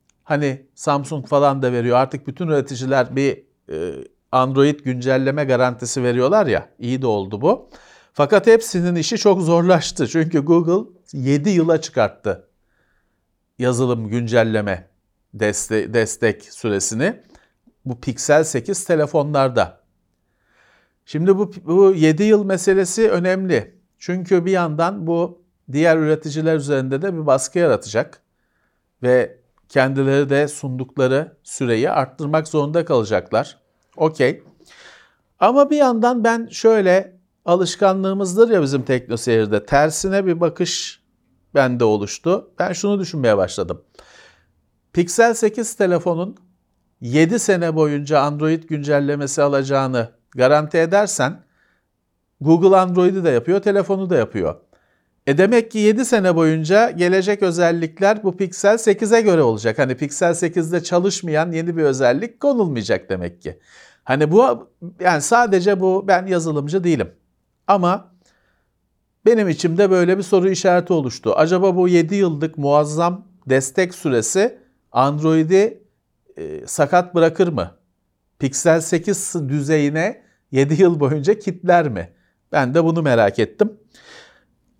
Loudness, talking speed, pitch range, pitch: -18 LUFS, 115 wpm, 135-190 Hz, 165 Hz